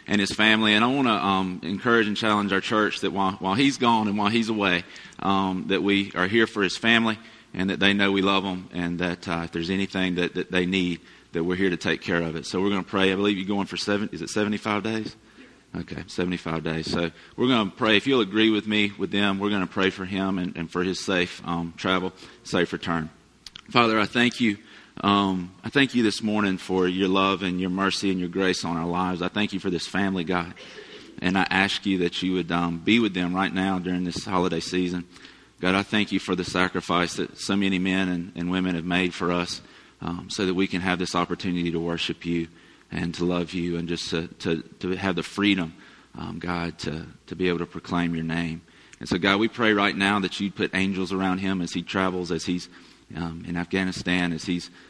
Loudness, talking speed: -24 LUFS, 240 wpm